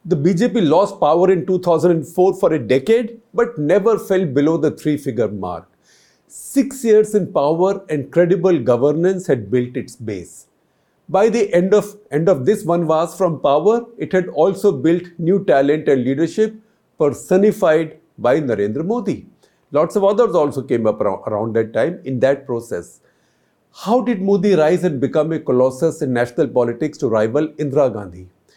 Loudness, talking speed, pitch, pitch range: -17 LUFS, 165 wpm, 165 Hz, 140-195 Hz